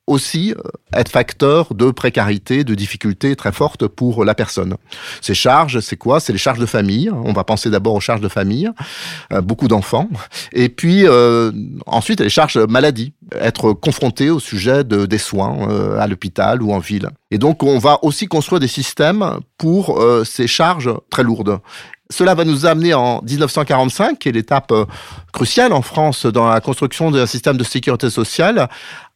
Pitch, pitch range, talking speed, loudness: 125 Hz, 110-150 Hz, 175 wpm, -15 LUFS